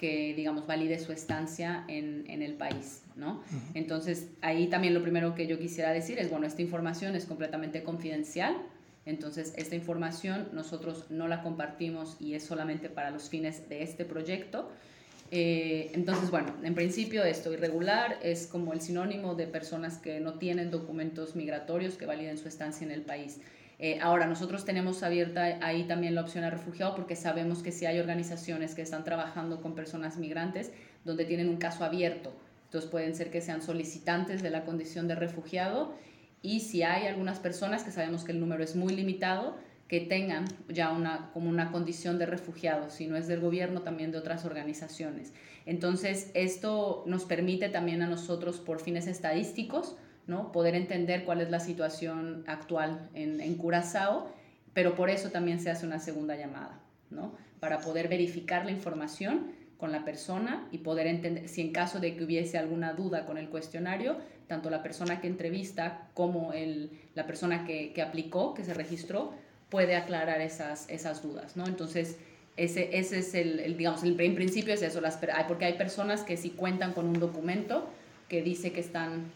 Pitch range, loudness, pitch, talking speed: 160-180 Hz, -34 LUFS, 170 Hz, 180 wpm